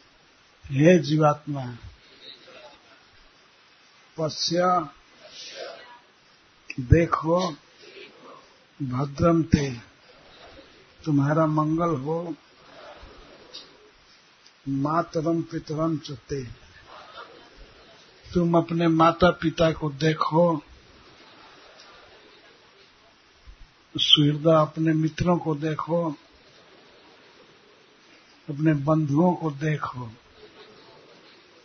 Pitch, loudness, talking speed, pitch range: 160 Hz, -23 LUFS, 50 wpm, 145-165 Hz